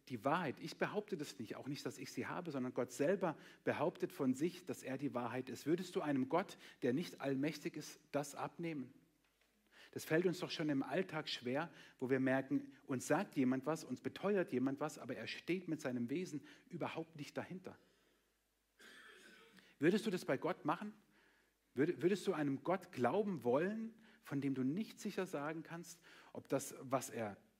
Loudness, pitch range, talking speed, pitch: -41 LUFS, 135-180 Hz, 185 wpm, 155 Hz